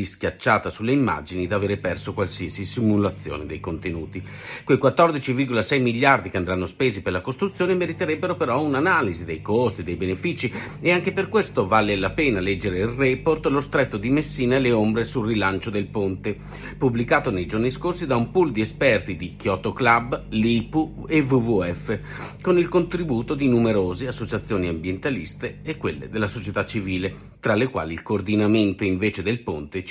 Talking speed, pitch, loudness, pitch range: 165 wpm, 115 Hz, -23 LUFS, 95-135 Hz